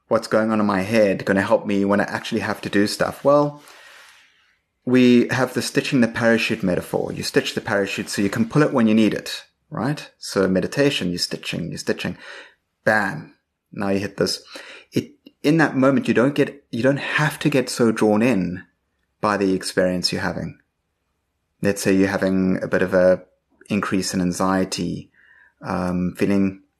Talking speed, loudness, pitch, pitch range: 185 wpm, -20 LUFS, 100 Hz, 95-115 Hz